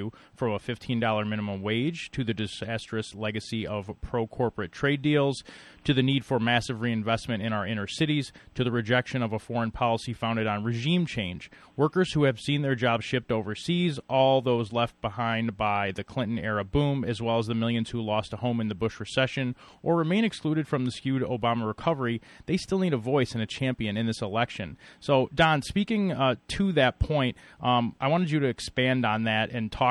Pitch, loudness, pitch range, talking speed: 120 Hz, -27 LUFS, 110-135 Hz, 205 wpm